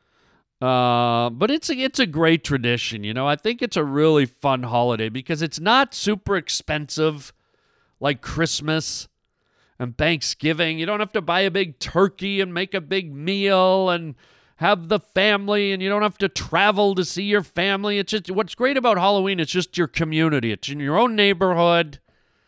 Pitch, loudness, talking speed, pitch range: 170 Hz, -21 LUFS, 175 wpm, 145-200 Hz